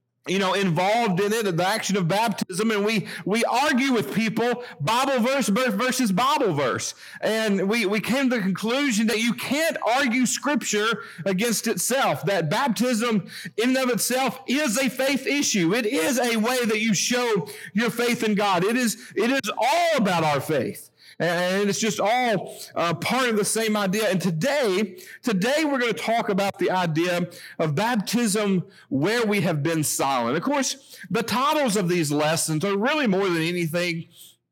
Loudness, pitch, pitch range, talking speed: -23 LUFS, 215 Hz, 190-245 Hz, 175 wpm